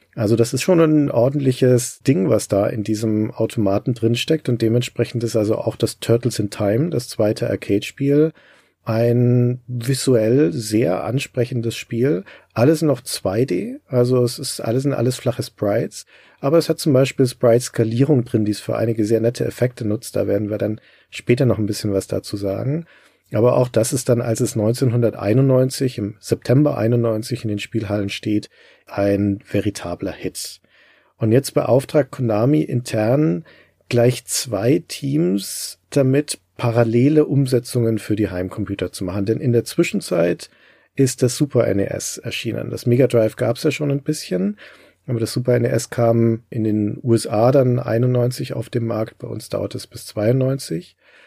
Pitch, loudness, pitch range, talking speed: 120 Hz, -19 LUFS, 110-135 Hz, 165 wpm